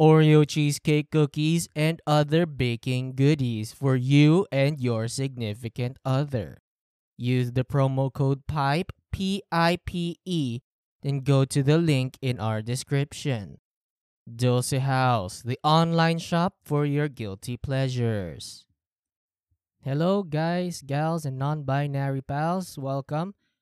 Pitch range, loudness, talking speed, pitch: 125-155 Hz, -25 LUFS, 120 wpm, 140 Hz